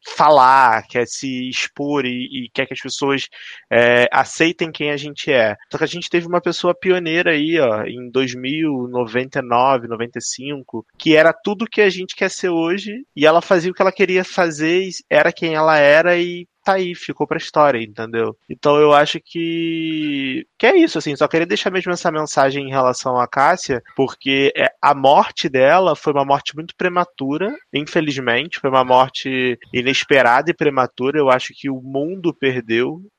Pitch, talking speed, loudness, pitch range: 150 Hz, 180 wpm, -17 LUFS, 130-175 Hz